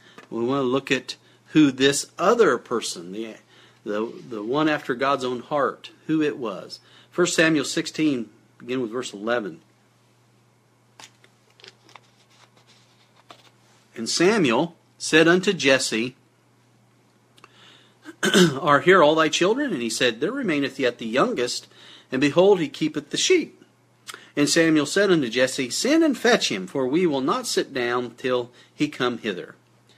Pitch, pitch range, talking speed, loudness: 140 Hz, 125-160 Hz, 140 wpm, -22 LUFS